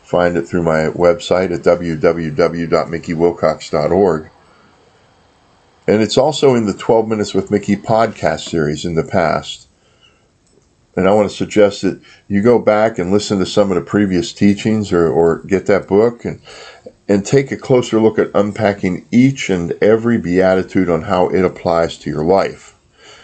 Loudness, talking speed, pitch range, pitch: -15 LUFS, 160 wpm, 85-105 Hz, 95 Hz